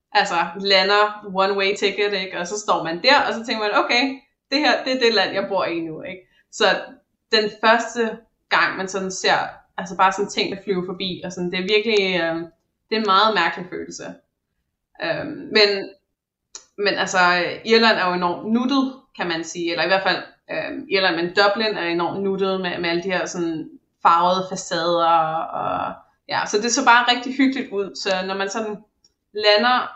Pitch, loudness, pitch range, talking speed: 195 Hz, -20 LUFS, 180-225 Hz, 195 wpm